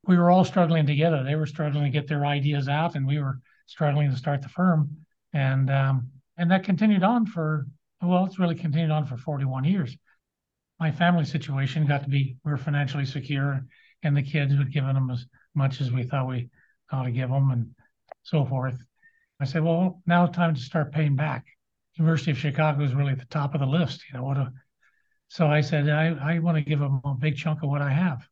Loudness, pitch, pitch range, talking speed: -25 LUFS, 150 Hz, 135-165 Hz, 225 wpm